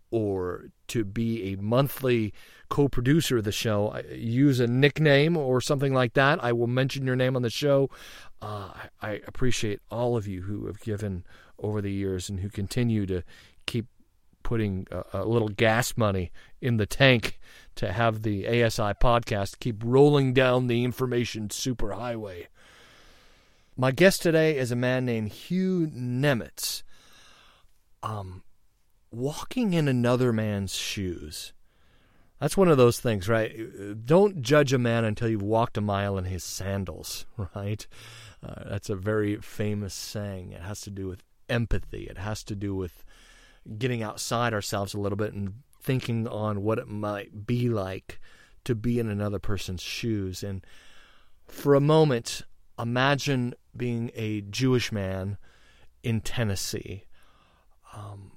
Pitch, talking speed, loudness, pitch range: 110 Hz, 150 wpm, -27 LUFS, 100-125 Hz